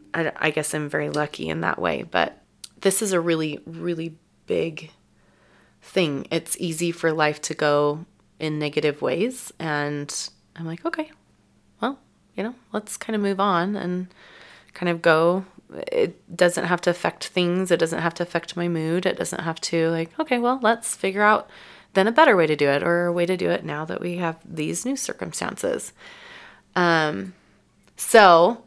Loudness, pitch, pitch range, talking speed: -23 LUFS, 170 Hz, 155-195 Hz, 180 wpm